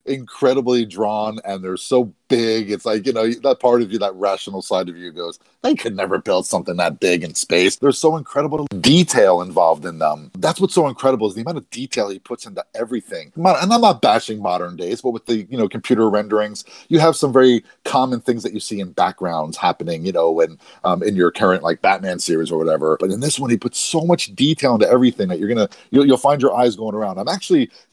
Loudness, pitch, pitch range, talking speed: -18 LUFS, 115 Hz, 100-135 Hz, 235 wpm